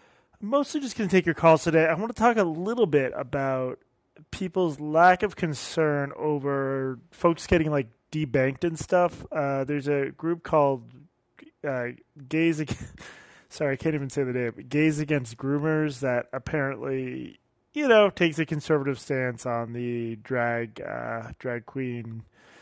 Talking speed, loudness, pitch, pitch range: 155 wpm, -26 LUFS, 145 Hz, 130-165 Hz